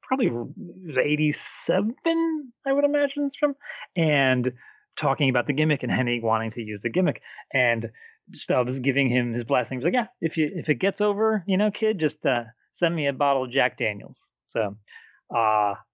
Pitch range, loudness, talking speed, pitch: 125-210 Hz, -25 LUFS, 175 wpm, 150 Hz